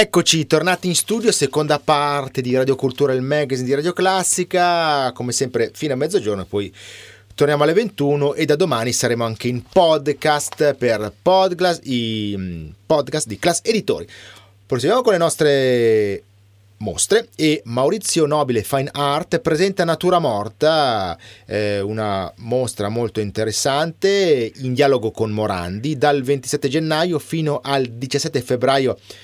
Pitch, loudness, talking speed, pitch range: 140 Hz, -18 LUFS, 130 wpm, 110-155 Hz